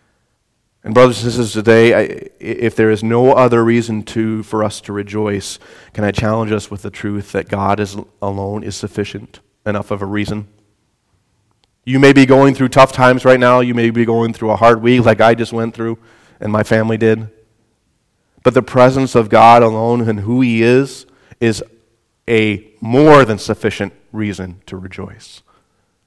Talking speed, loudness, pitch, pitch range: 180 wpm, -13 LUFS, 110 Hz, 105-120 Hz